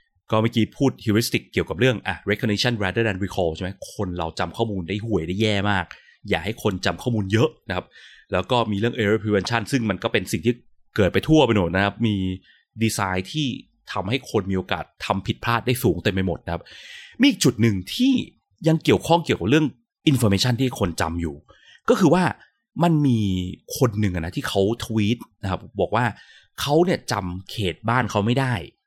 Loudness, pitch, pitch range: -22 LUFS, 110 Hz, 95-125 Hz